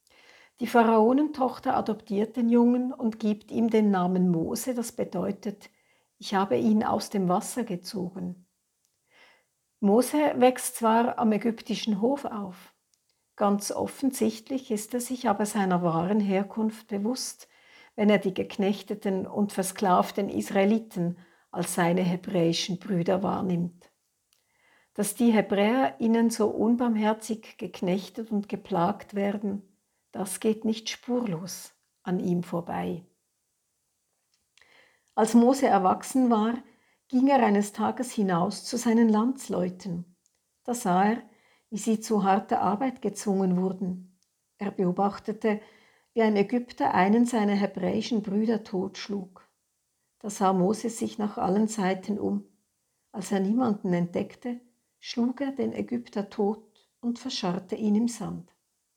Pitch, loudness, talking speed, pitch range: 210 Hz, -27 LUFS, 120 wpm, 190-235 Hz